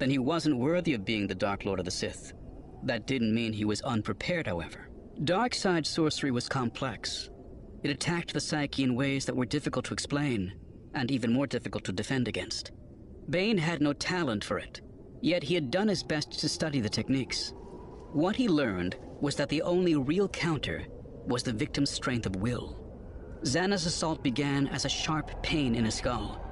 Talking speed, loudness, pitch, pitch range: 190 wpm, -30 LUFS, 135 Hz, 110-155 Hz